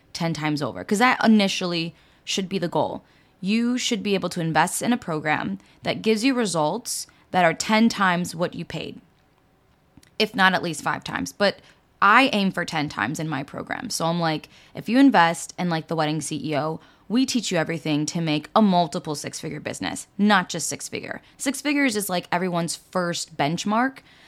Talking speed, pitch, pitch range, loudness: 195 wpm, 175 Hz, 160-215 Hz, -23 LUFS